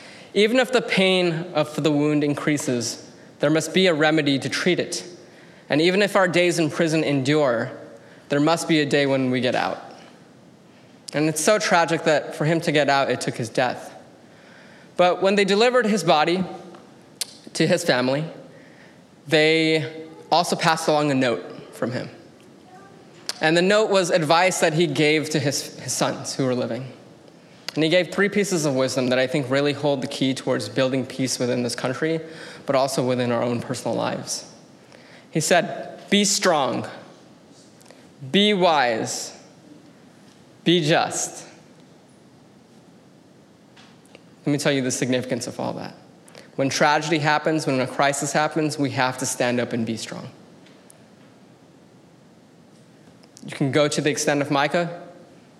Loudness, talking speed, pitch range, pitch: -21 LUFS, 160 wpm, 135-175 Hz, 155 Hz